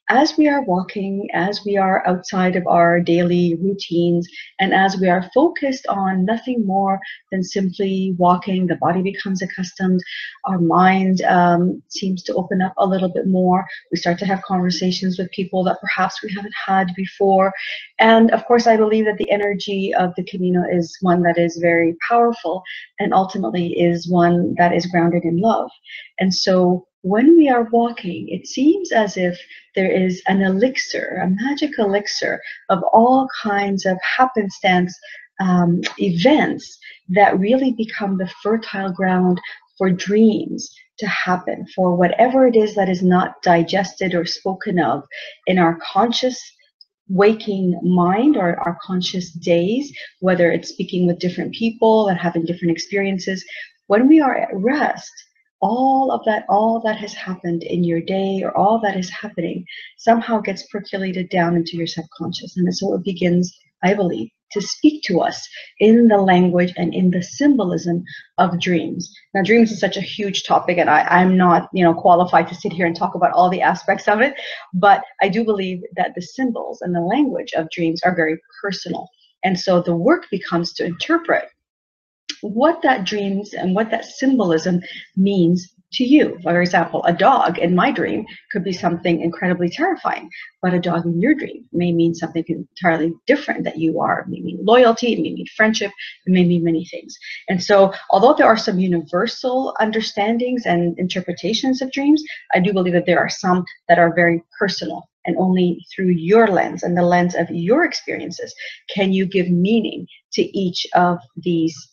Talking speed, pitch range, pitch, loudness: 175 wpm, 175-215 Hz, 190 Hz, -18 LUFS